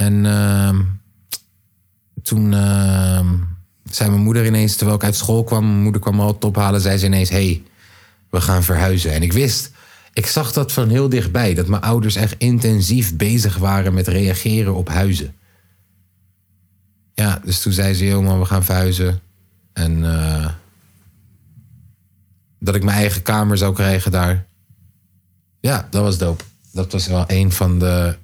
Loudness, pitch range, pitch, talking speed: -17 LUFS, 95-105 Hz, 95 Hz, 160 wpm